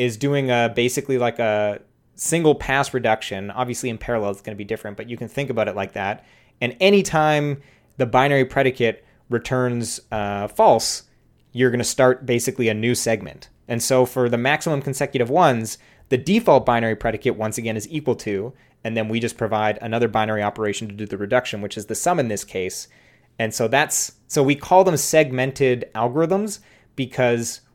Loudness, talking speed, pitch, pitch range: -21 LUFS, 185 wpm, 120 Hz, 110-135 Hz